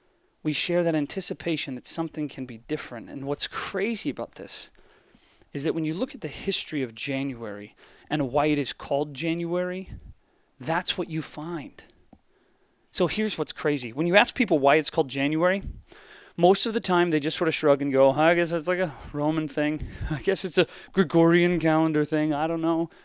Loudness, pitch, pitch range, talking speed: -25 LUFS, 160 Hz, 145-180 Hz, 195 wpm